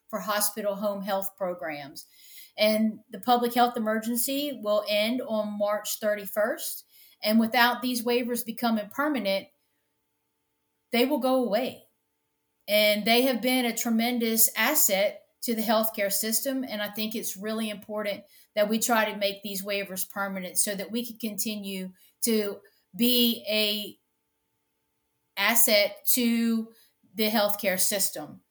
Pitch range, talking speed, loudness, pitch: 205-240 Hz, 135 wpm, -26 LUFS, 220 Hz